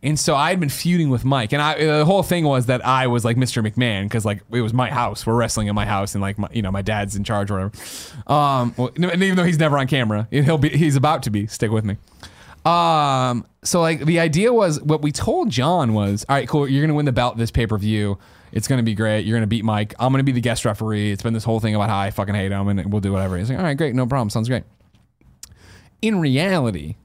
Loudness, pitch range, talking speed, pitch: -20 LUFS, 105-145 Hz, 270 wpm, 120 Hz